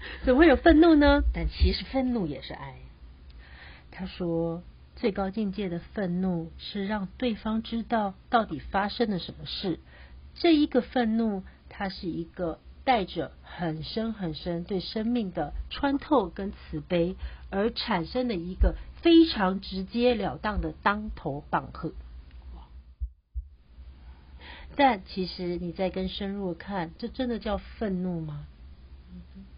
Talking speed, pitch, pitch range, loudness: 195 characters per minute, 185 Hz, 155-225 Hz, -28 LUFS